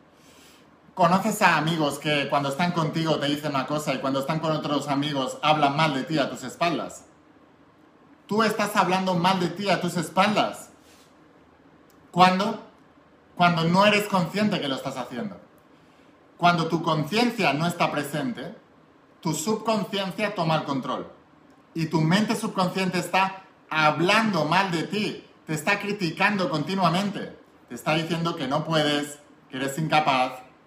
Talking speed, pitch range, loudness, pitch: 145 wpm, 150-195 Hz, -24 LUFS, 170 Hz